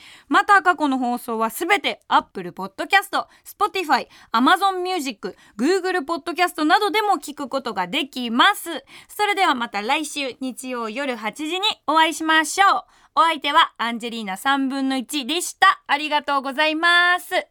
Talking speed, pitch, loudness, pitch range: 390 characters per minute, 305 Hz, -20 LUFS, 260-360 Hz